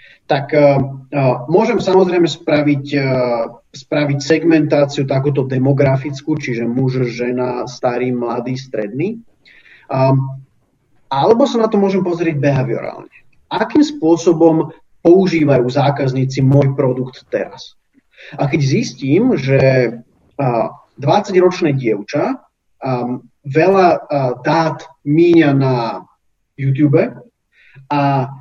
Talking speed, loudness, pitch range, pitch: 100 wpm, -15 LUFS, 130-160 Hz, 140 Hz